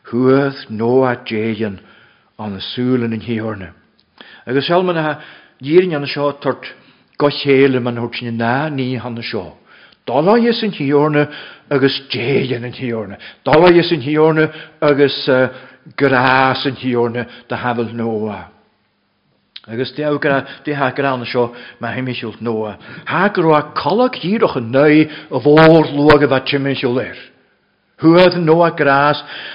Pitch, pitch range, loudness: 135 Hz, 120-150 Hz, -15 LUFS